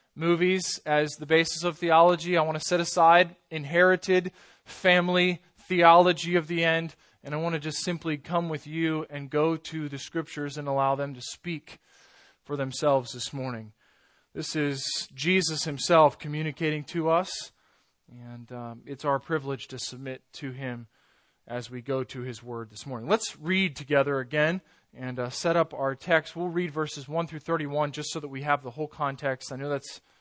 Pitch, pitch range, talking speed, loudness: 155 Hz, 135-170 Hz, 180 wpm, -27 LUFS